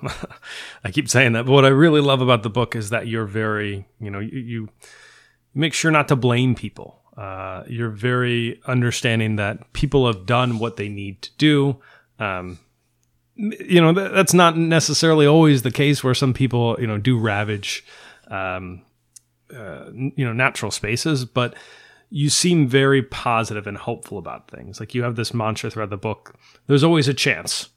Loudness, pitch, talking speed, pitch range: -19 LUFS, 120 Hz, 180 wpm, 105-140 Hz